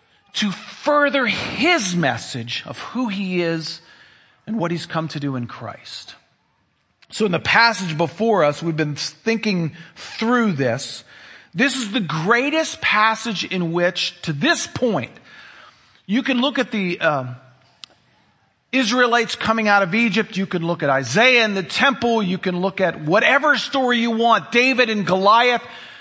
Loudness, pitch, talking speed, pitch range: -19 LUFS, 205 Hz, 155 wpm, 170-235 Hz